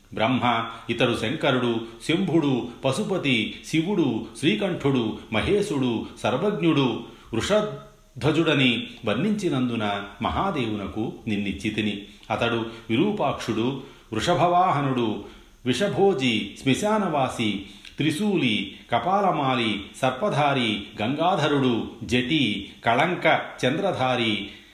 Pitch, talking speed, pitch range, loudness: 120 Hz, 60 wpm, 110-150 Hz, -24 LUFS